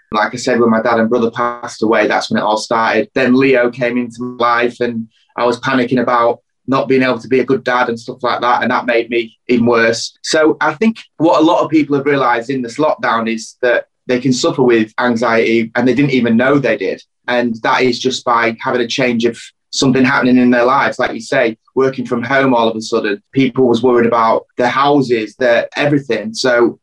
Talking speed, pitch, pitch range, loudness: 235 wpm, 120 Hz, 115-130 Hz, -14 LUFS